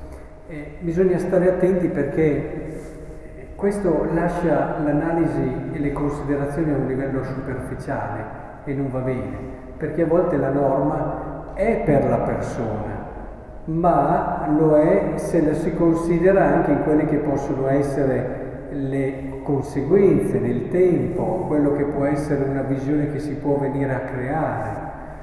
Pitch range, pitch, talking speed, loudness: 135-165 Hz, 145 Hz, 135 wpm, -21 LUFS